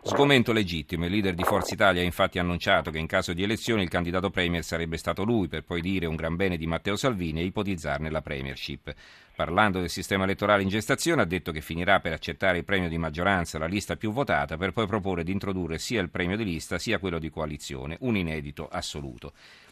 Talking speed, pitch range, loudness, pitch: 215 wpm, 80-100 Hz, -27 LUFS, 90 Hz